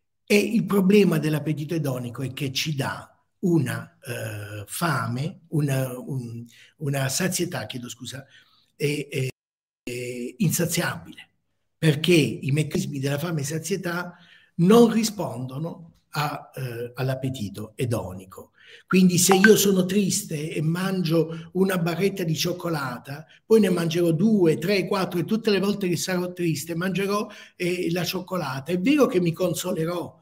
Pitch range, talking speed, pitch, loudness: 135-185 Hz, 135 wpm, 165 Hz, -24 LUFS